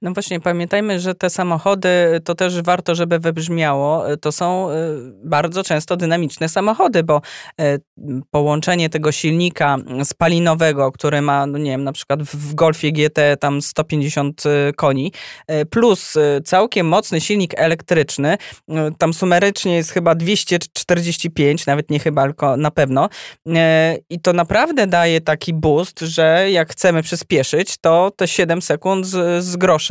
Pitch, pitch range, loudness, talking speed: 165 Hz, 150-180 Hz, -17 LUFS, 135 wpm